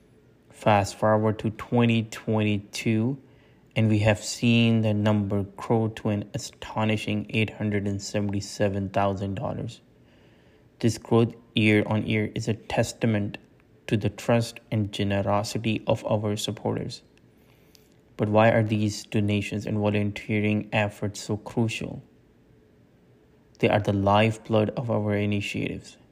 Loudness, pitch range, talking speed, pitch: -26 LUFS, 105-115 Hz, 110 wpm, 105 Hz